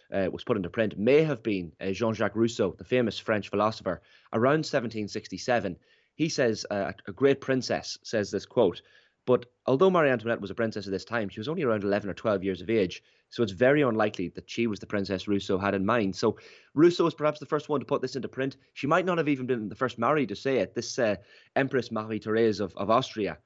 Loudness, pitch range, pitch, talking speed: -28 LUFS, 100-135 Hz, 115 Hz, 235 wpm